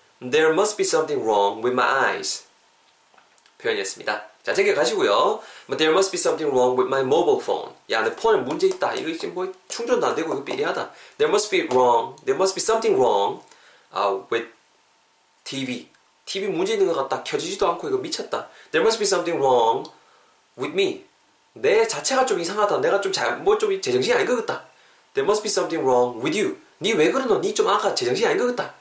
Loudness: -21 LUFS